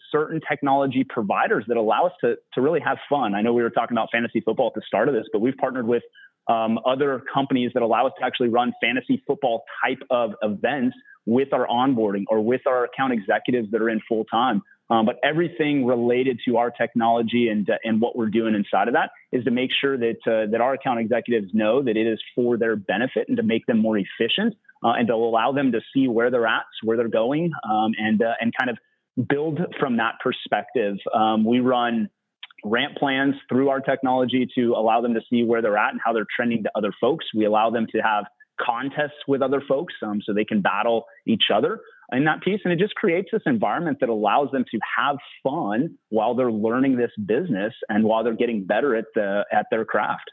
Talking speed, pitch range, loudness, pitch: 220 wpm, 115-135 Hz, -22 LUFS, 120 Hz